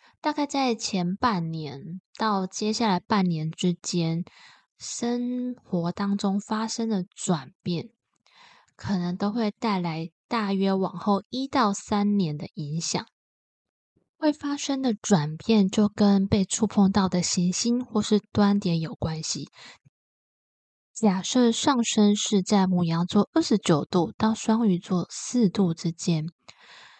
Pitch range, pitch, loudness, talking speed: 180-225 Hz, 200 Hz, -25 LUFS, 185 characters per minute